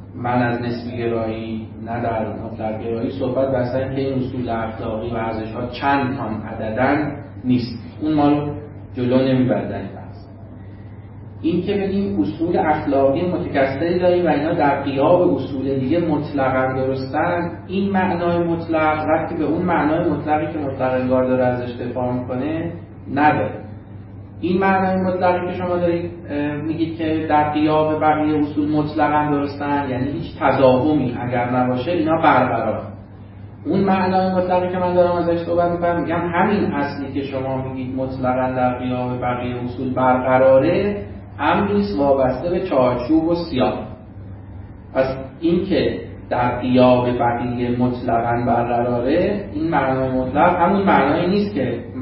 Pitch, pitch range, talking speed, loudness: 130 Hz, 120-155 Hz, 135 wpm, -19 LUFS